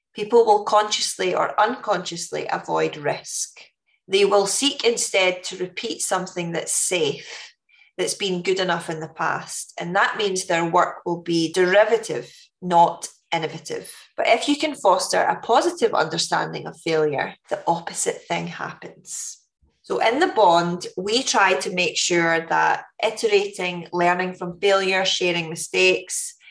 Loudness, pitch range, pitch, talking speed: -21 LUFS, 170-230 Hz, 190 Hz, 145 wpm